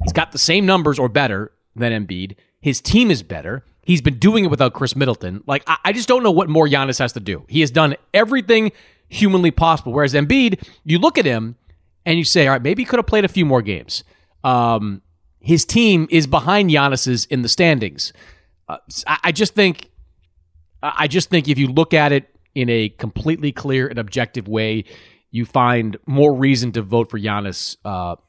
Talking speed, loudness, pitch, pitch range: 200 wpm, -17 LUFS, 135 Hz, 110-165 Hz